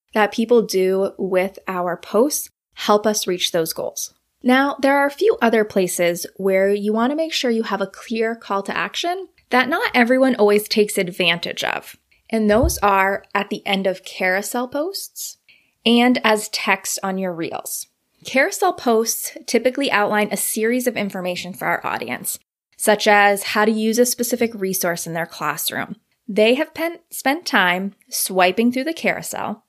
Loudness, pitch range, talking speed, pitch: -19 LUFS, 195-250 Hz, 170 wpm, 215 Hz